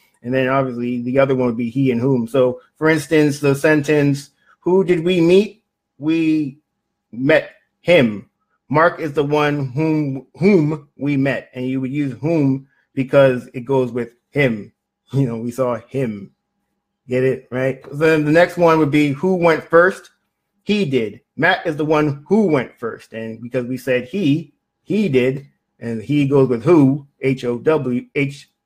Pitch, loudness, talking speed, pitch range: 140 Hz, -18 LUFS, 175 wpm, 130-155 Hz